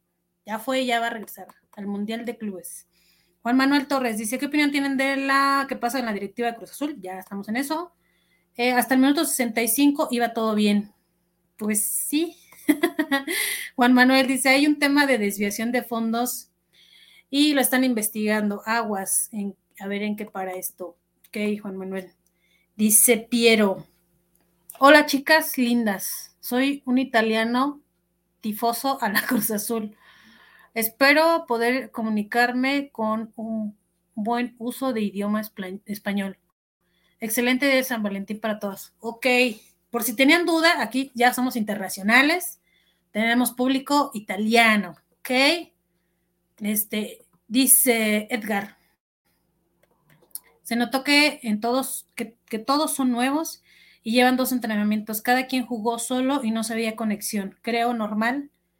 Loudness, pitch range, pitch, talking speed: -22 LUFS, 205-260 Hz, 230 Hz, 140 wpm